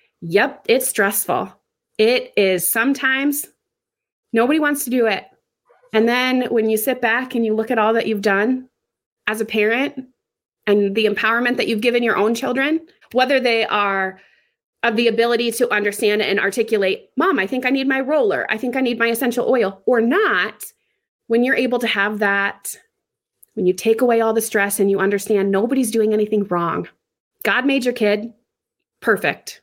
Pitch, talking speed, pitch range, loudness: 230 Hz, 180 wpm, 210-255 Hz, -18 LUFS